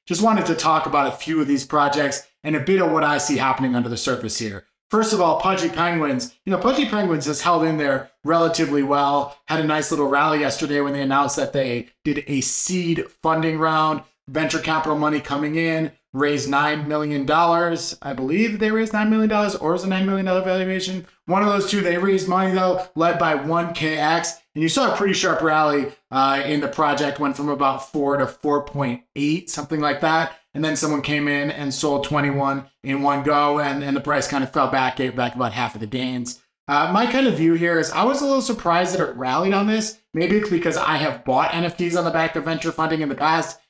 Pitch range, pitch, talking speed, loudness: 140-170 Hz, 155 Hz, 225 wpm, -21 LUFS